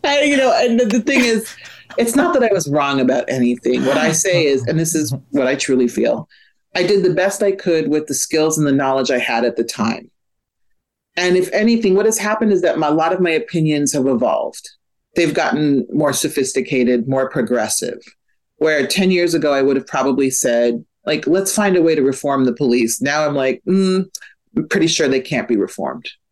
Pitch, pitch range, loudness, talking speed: 155 Hz, 135-190 Hz, -16 LUFS, 215 wpm